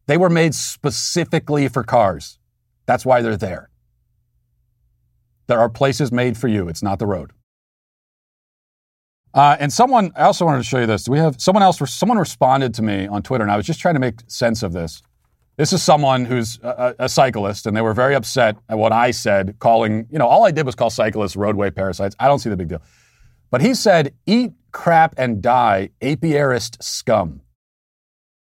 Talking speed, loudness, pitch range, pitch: 195 wpm, -17 LUFS, 105-145 Hz, 120 Hz